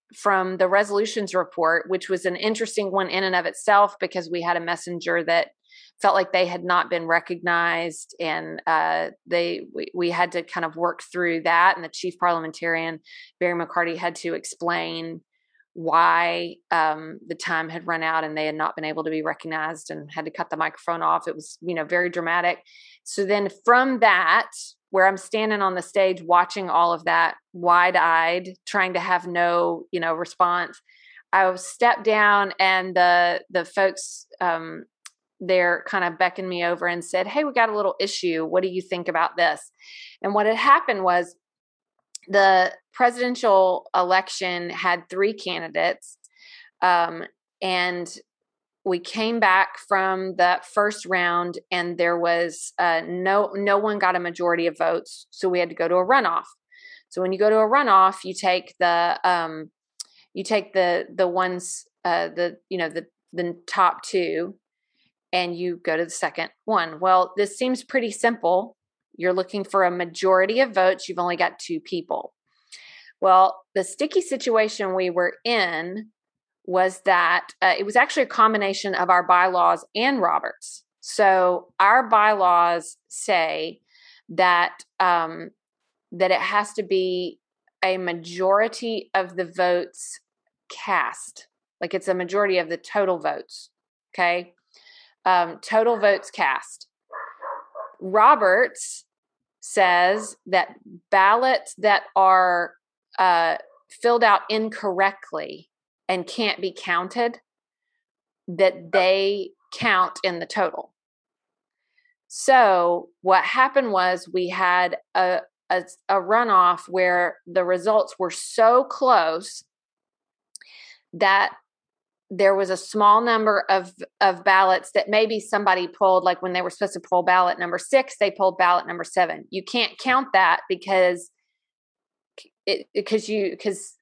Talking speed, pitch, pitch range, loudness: 150 wpm, 185 Hz, 175-205 Hz, -21 LUFS